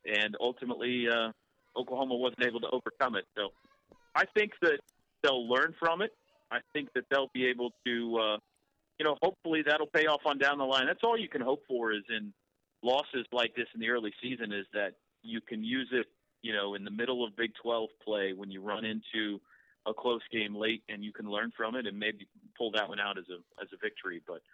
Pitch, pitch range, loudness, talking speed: 120 Hz, 110-145 Hz, -33 LUFS, 225 wpm